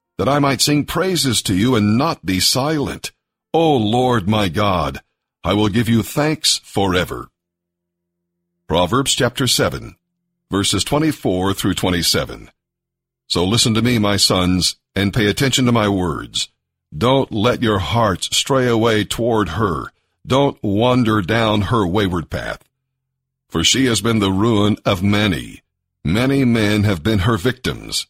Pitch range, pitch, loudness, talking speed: 95-130 Hz, 110 Hz, -17 LUFS, 145 wpm